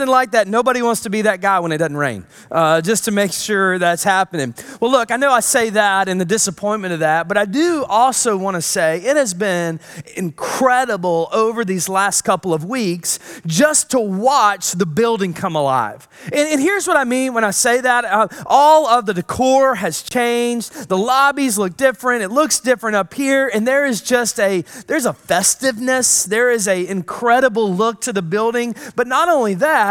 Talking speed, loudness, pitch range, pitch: 205 wpm, -16 LUFS, 190-255 Hz, 220 Hz